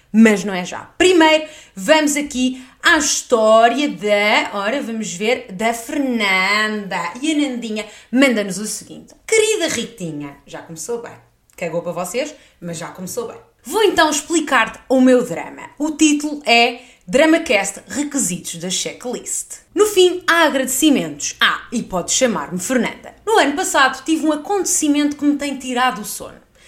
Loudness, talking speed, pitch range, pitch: -17 LUFS, 150 wpm, 210-305 Hz, 255 Hz